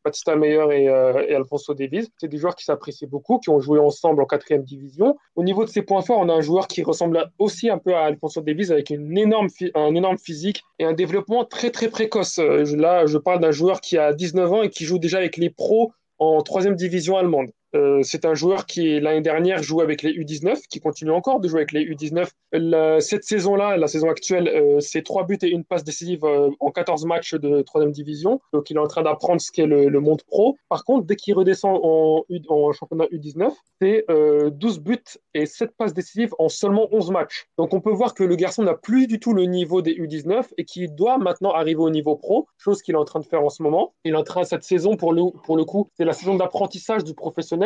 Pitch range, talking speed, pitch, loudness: 155-195 Hz, 240 wpm, 170 Hz, -20 LUFS